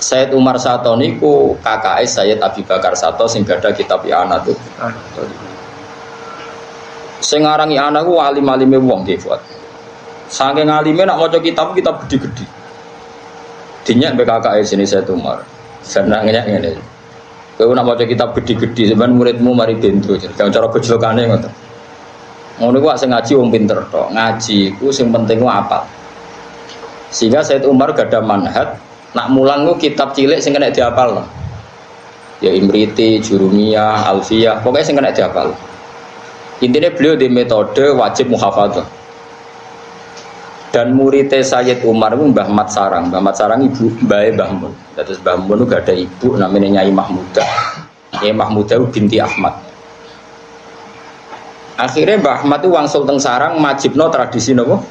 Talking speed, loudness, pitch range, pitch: 145 wpm, -12 LUFS, 110-135 Hz, 120 Hz